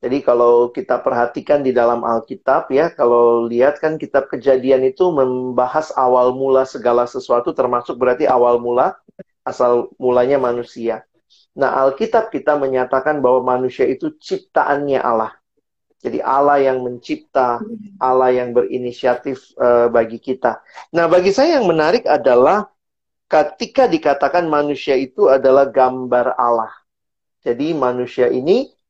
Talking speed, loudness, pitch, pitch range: 125 wpm, -16 LUFS, 130 Hz, 120-145 Hz